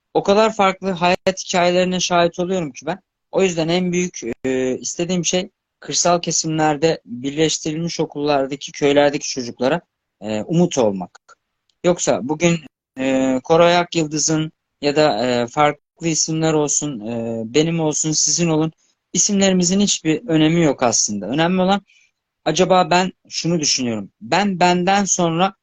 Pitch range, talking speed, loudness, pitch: 145-180 Hz, 130 wpm, -18 LUFS, 160 Hz